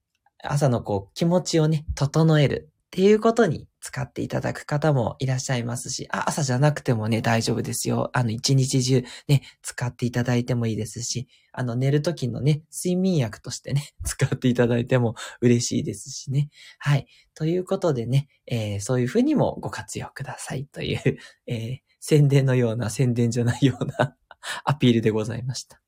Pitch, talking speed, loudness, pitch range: 130 Hz, 355 characters per minute, -24 LUFS, 120-150 Hz